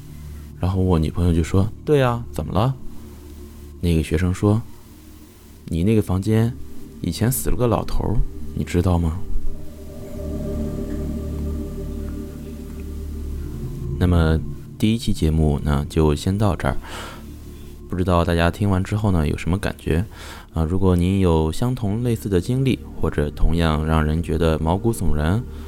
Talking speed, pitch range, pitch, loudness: 200 characters per minute, 75-95 Hz, 80 Hz, -22 LUFS